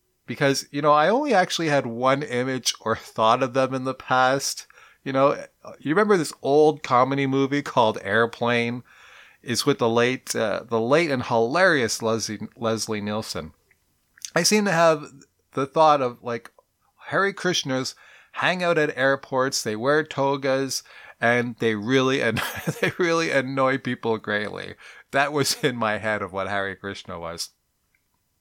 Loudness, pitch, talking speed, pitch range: -23 LUFS, 130 Hz, 155 wpm, 115-145 Hz